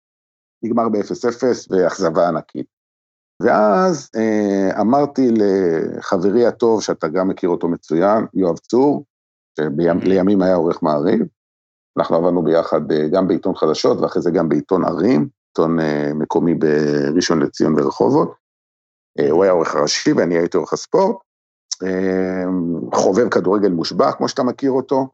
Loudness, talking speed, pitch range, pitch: -17 LUFS, 125 wpm, 75-110 Hz, 95 Hz